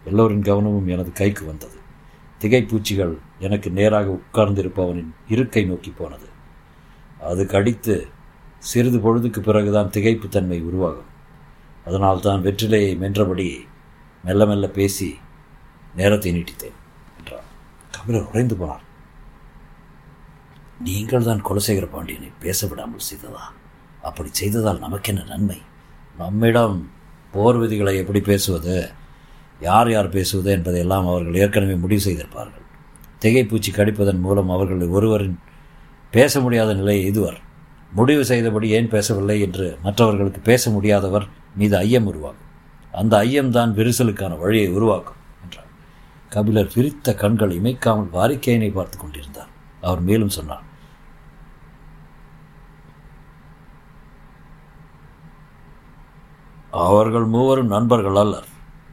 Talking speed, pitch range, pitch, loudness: 100 wpm, 90-110 Hz, 100 Hz, -19 LUFS